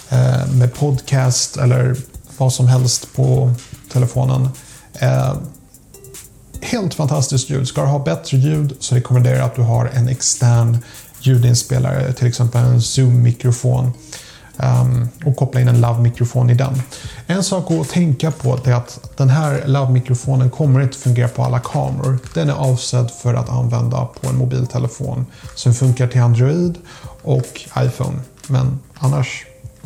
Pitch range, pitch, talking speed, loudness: 125-135 Hz, 130 Hz, 145 wpm, -16 LUFS